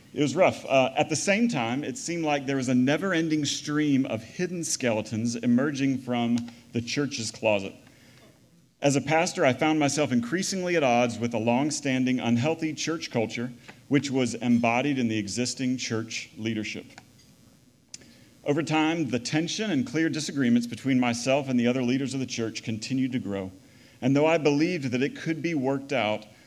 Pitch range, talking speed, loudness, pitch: 120-155 Hz, 175 wpm, -26 LUFS, 130 Hz